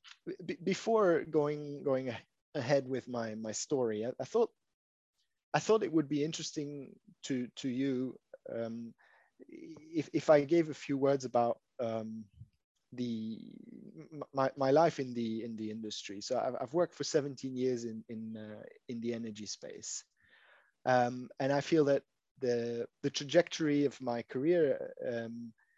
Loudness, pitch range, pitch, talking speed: -34 LUFS, 115-155 Hz, 135 Hz, 150 wpm